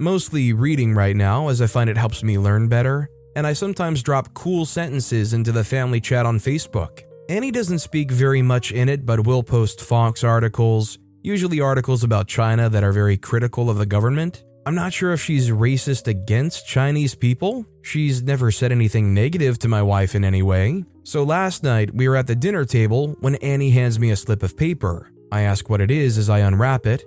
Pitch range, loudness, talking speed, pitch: 110-140 Hz, -19 LUFS, 205 wpm, 120 Hz